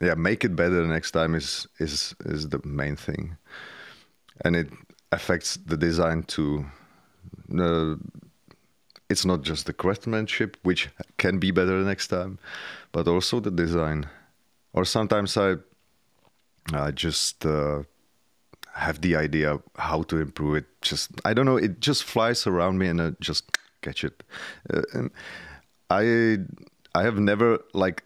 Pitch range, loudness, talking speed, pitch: 75-95 Hz, -26 LUFS, 145 wpm, 85 Hz